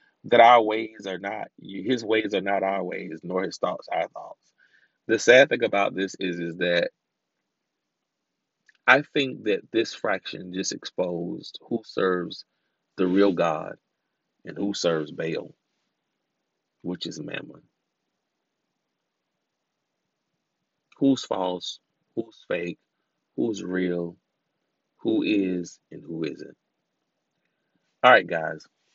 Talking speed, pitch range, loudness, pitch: 120 wpm, 90-100 Hz, -24 LUFS, 95 Hz